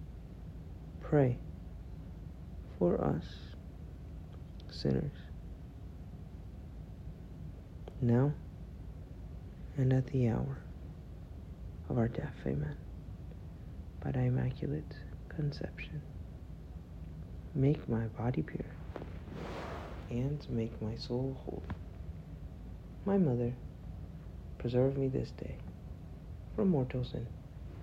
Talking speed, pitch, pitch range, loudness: 75 wpm, 85 Hz, 80-115 Hz, -36 LUFS